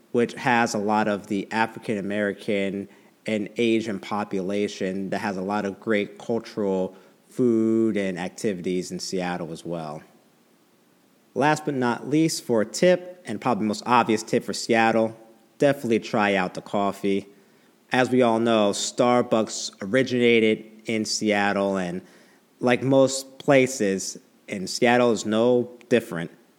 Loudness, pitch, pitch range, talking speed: -24 LUFS, 110 Hz, 100-120 Hz, 140 wpm